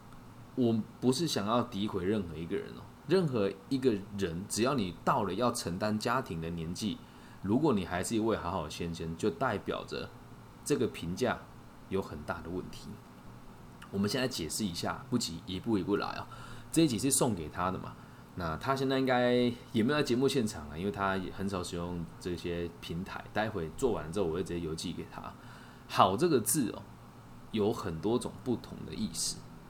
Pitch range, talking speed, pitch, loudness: 85-120 Hz, 280 characters per minute, 100 Hz, -33 LUFS